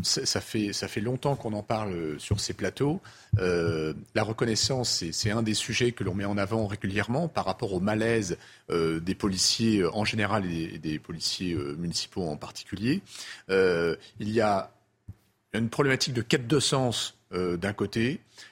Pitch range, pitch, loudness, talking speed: 95-115 Hz, 105 Hz, -28 LUFS, 170 wpm